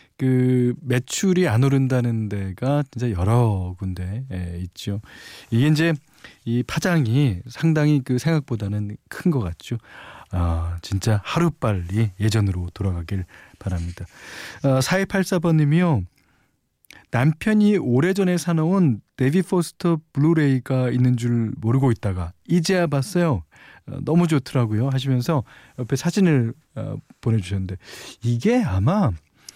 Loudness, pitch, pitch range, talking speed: -22 LUFS, 125 Hz, 105-155 Hz, 260 characters per minute